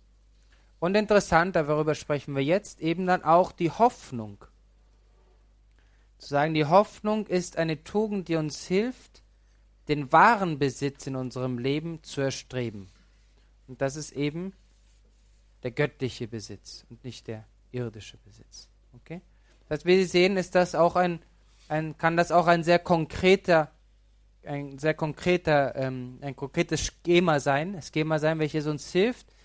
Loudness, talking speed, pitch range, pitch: -26 LUFS, 145 wpm, 120-175 Hz, 150 Hz